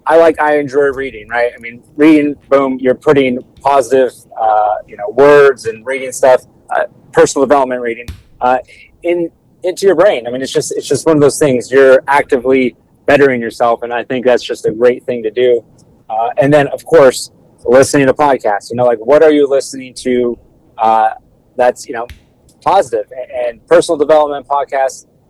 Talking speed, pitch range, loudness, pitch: 185 wpm, 125-155 Hz, -12 LUFS, 135 Hz